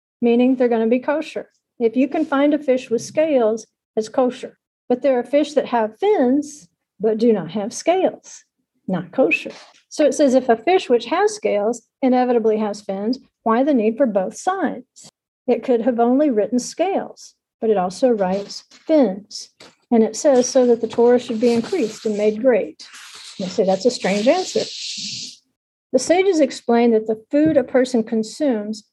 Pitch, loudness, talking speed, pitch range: 245 Hz, -19 LUFS, 180 wpm, 220-275 Hz